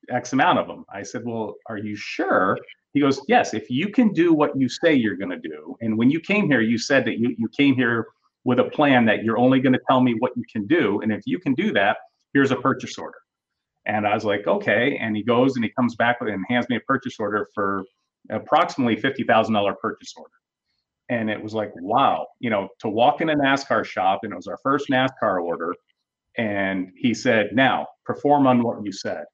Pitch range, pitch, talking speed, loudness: 105-135 Hz, 120 Hz, 230 wpm, -22 LUFS